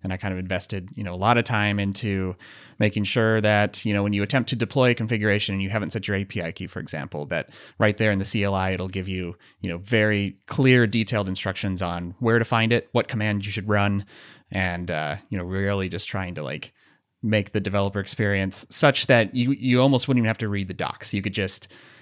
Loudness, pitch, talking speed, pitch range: -24 LUFS, 100 Hz, 235 wpm, 95-110 Hz